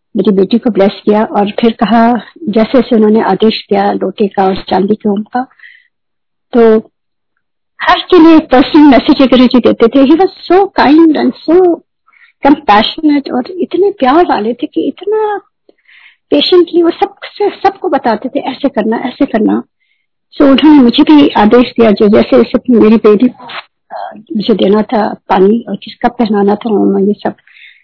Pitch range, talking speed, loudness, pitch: 215-320 Hz, 150 wpm, -9 LUFS, 250 Hz